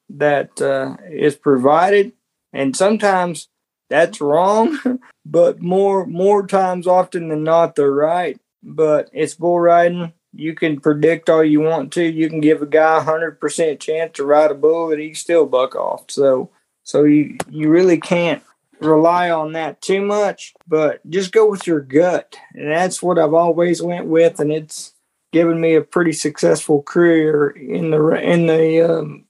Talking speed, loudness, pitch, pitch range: 170 wpm, -16 LUFS, 160 Hz, 155-175 Hz